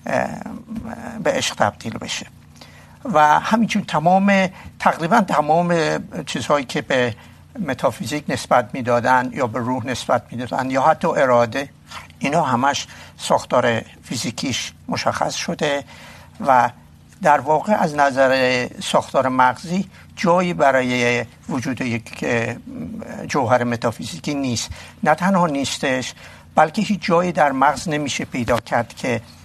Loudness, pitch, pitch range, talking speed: -19 LUFS, 135 Hz, 120-170 Hz, 115 wpm